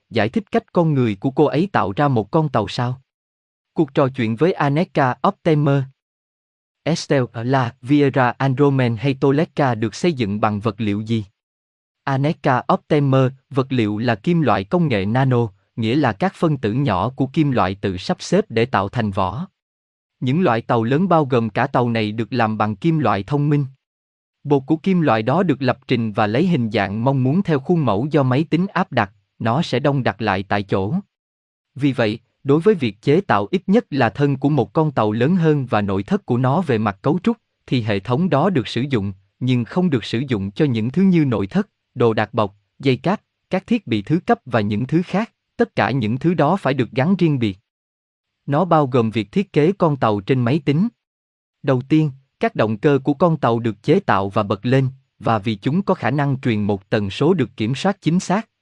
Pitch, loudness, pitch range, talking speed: 130 Hz, -19 LUFS, 110-155 Hz, 215 wpm